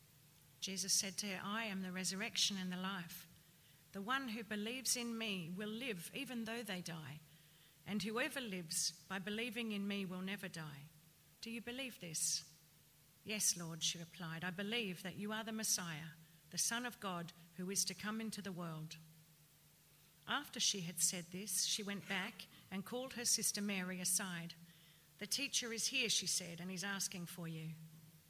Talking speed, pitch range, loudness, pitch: 180 wpm, 165-210 Hz, -41 LUFS, 185 Hz